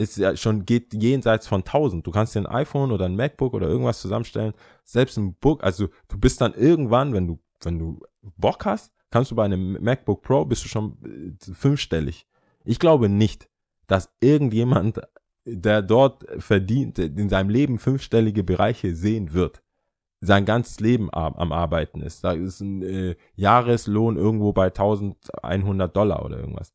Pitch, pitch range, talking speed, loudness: 105 Hz, 95-120 Hz, 160 wpm, -22 LUFS